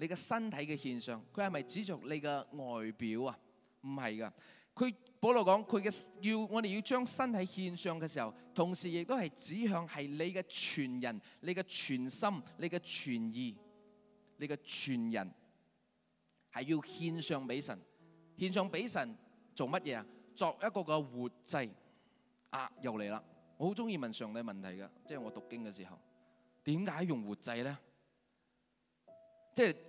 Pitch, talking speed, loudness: 165 Hz, 230 characters per minute, -39 LUFS